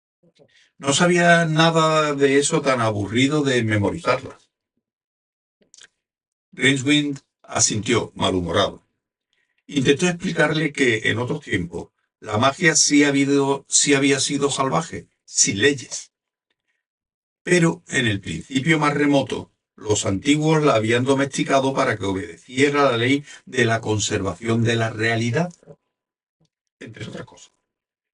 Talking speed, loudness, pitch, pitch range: 115 wpm, -19 LUFS, 140 Hz, 115-150 Hz